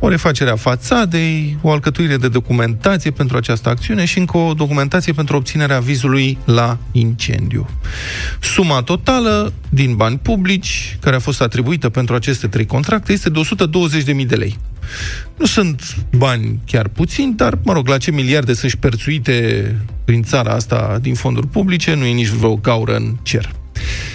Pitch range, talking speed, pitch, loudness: 115-160 Hz, 160 wpm, 130 Hz, -15 LUFS